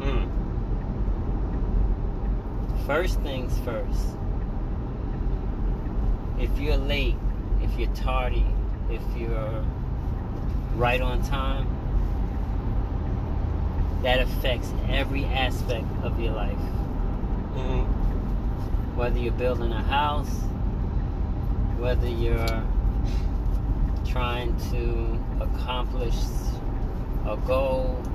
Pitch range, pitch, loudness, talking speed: 90-115 Hz, 100 Hz, -28 LUFS, 75 wpm